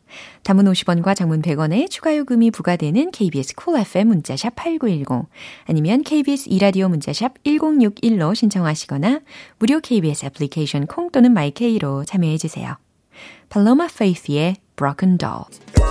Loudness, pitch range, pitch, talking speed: -18 LUFS, 160-250 Hz, 195 Hz, 360 characters per minute